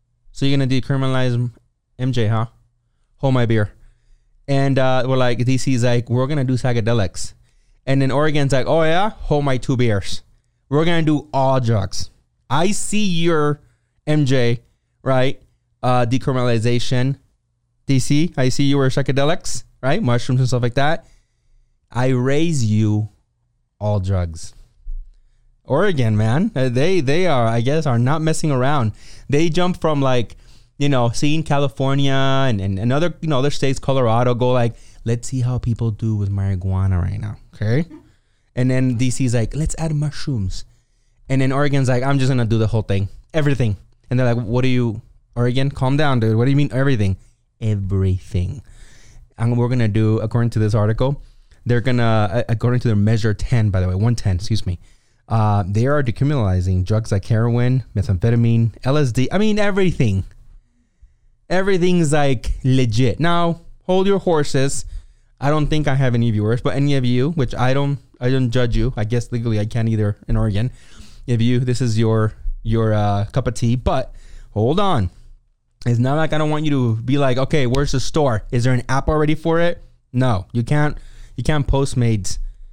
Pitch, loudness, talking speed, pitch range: 125 Hz, -19 LUFS, 175 wpm, 115-135 Hz